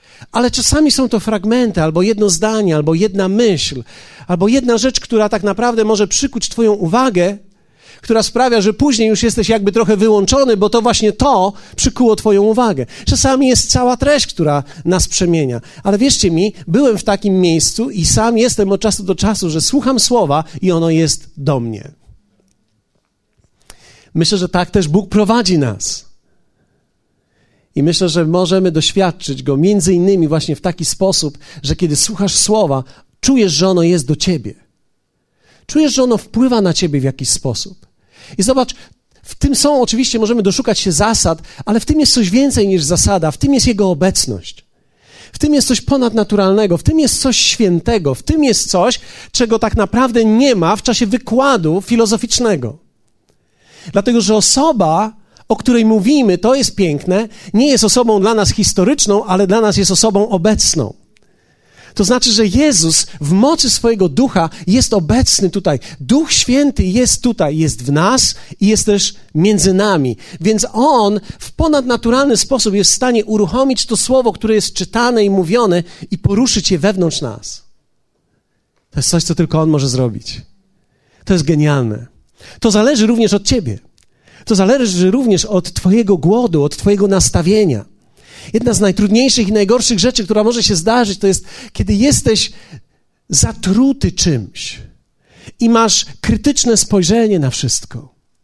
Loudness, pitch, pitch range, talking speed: -13 LUFS, 210 Hz, 175-235 Hz, 160 wpm